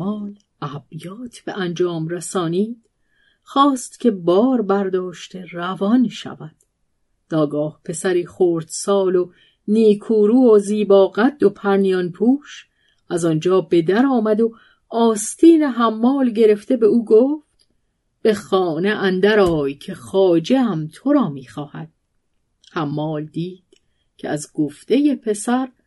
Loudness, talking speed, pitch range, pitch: -18 LUFS, 120 wpm, 175-230 Hz, 195 Hz